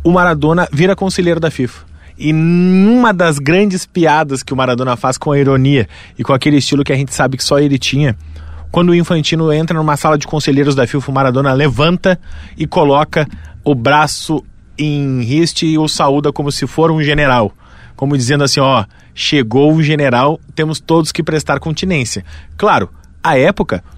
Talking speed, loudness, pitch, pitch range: 185 wpm, -13 LUFS, 145 Hz, 130-160 Hz